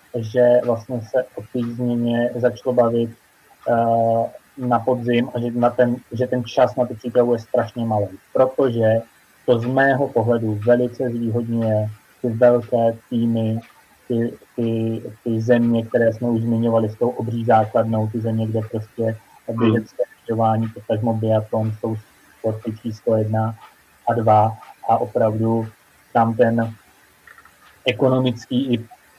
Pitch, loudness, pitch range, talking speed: 115 Hz, -20 LUFS, 110-120 Hz, 140 wpm